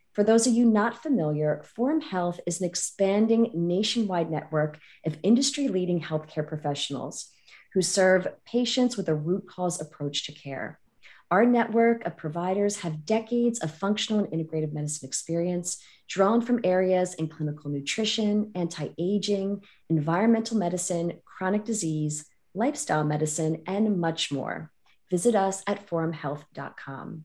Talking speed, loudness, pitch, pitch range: 135 wpm, -27 LUFS, 180 Hz, 155-210 Hz